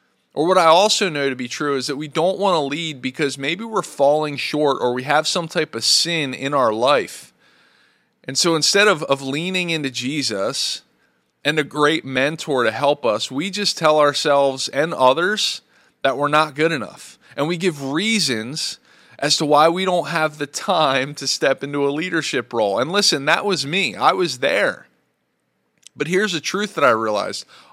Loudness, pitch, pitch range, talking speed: -19 LUFS, 150 Hz, 135-170 Hz, 195 wpm